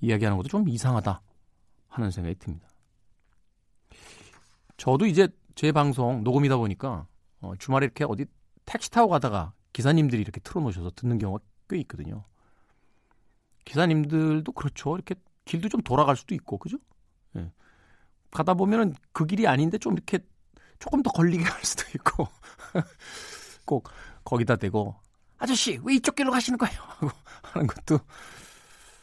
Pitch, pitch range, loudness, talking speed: 125 Hz, 100-170 Hz, -26 LUFS, 305 characters per minute